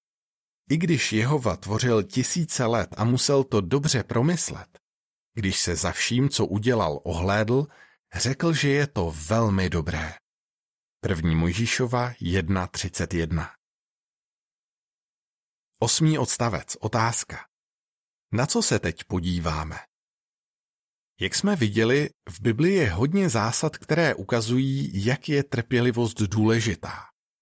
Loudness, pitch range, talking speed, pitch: -24 LUFS, 95-135 Hz, 110 wpm, 115 Hz